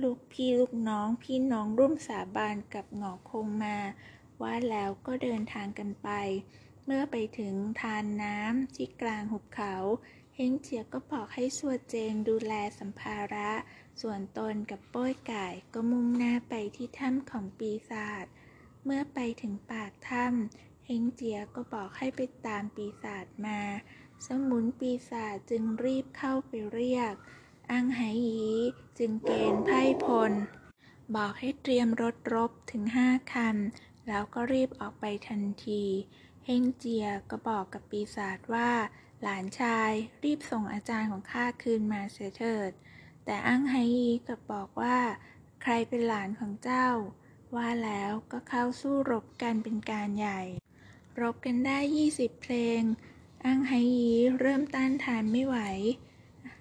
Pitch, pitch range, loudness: 230 Hz, 210-250 Hz, -32 LUFS